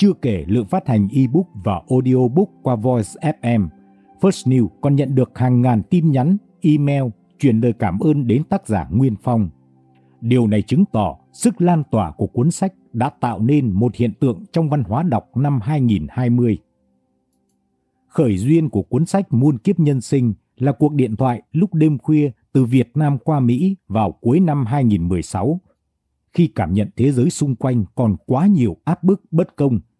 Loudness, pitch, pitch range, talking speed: -18 LUFS, 125 Hz, 110-150 Hz, 180 wpm